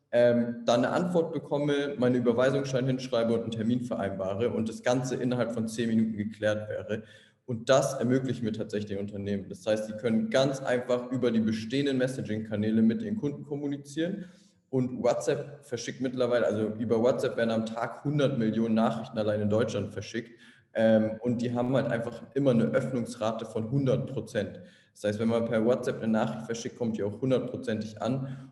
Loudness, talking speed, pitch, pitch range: -29 LUFS, 175 wpm, 115 Hz, 110-130 Hz